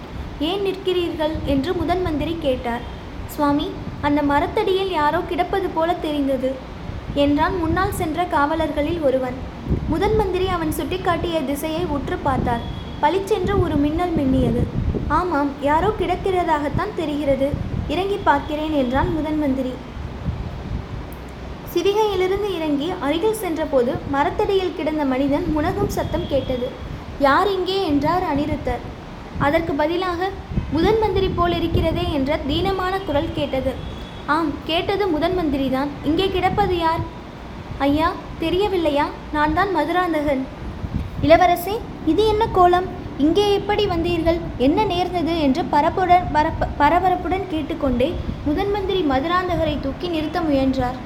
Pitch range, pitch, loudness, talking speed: 290-365 Hz, 325 Hz, -21 LUFS, 105 wpm